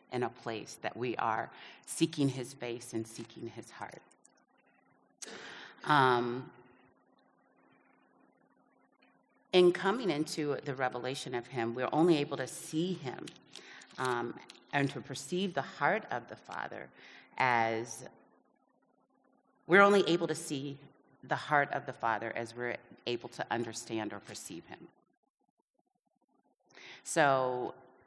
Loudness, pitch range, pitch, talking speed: -33 LUFS, 120-160 Hz, 135 Hz, 120 wpm